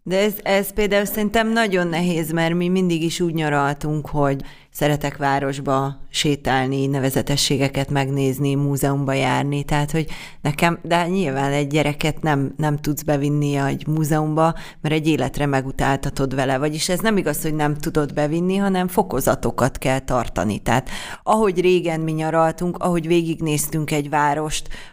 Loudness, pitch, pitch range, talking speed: -20 LUFS, 150 Hz, 140-170 Hz, 145 wpm